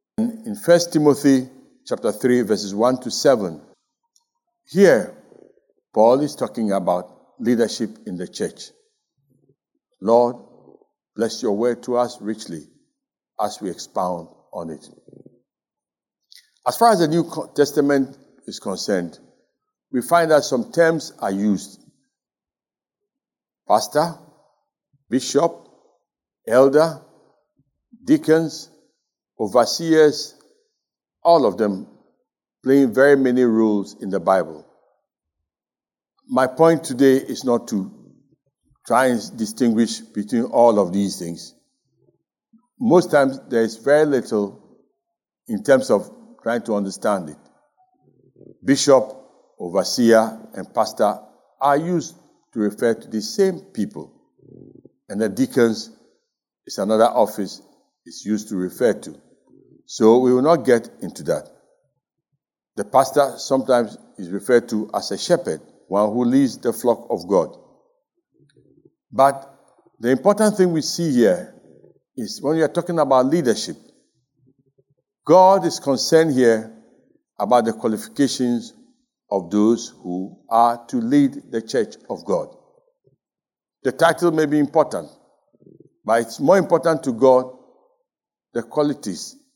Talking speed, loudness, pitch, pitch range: 120 wpm, -19 LUFS, 140 Hz, 120-185 Hz